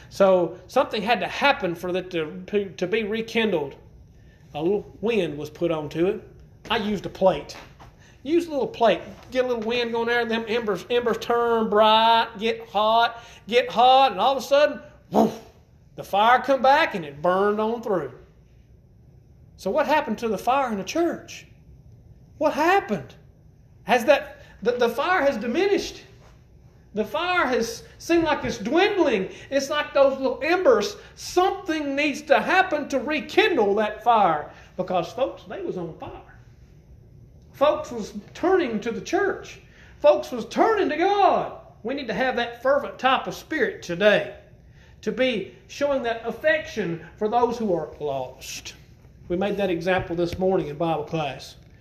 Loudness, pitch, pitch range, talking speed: -23 LUFS, 235 Hz, 195-285 Hz, 165 wpm